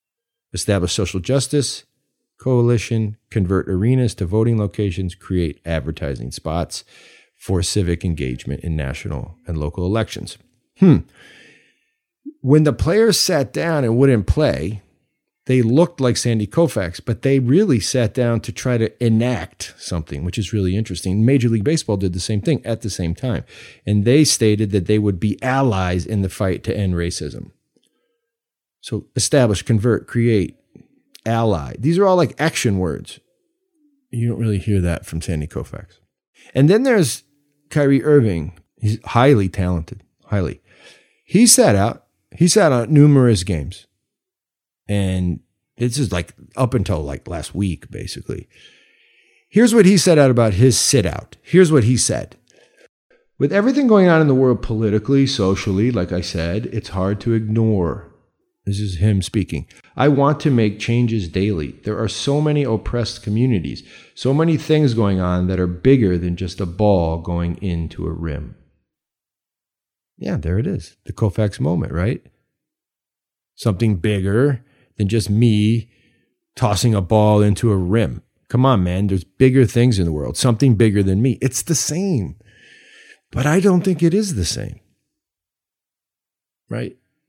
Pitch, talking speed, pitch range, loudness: 110 Hz, 155 wpm, 95-135 Hz, -18 LUFS